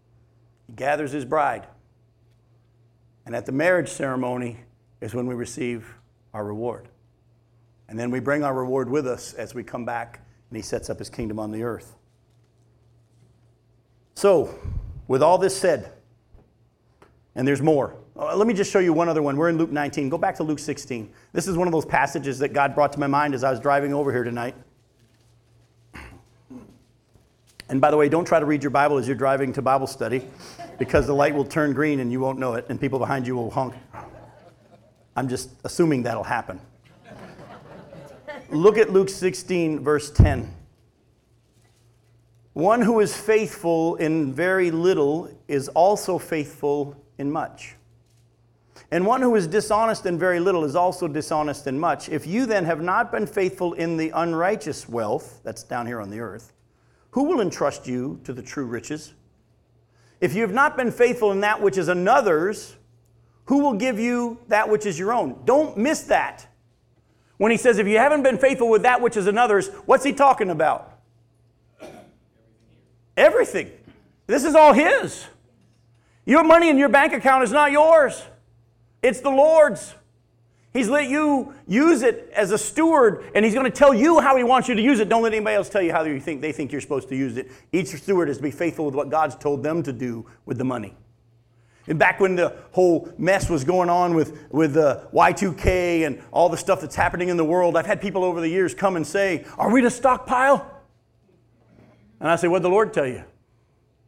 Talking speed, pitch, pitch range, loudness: 190 wpm, 145 Hz, 120-195 Hz, -21 LUFS